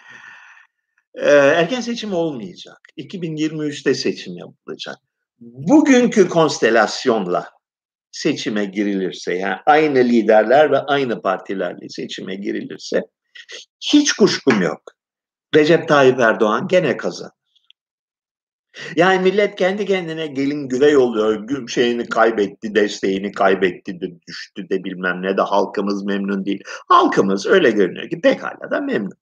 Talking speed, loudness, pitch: 110 wpm, -17 LUFS, 155 Hz